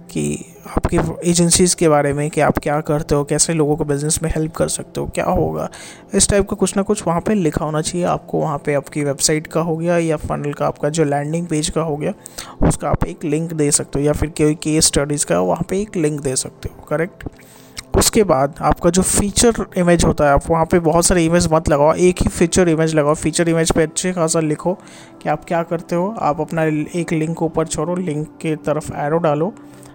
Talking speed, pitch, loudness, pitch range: 230 wpm, 160 Hz, -17 LUFS, 150-175 Hz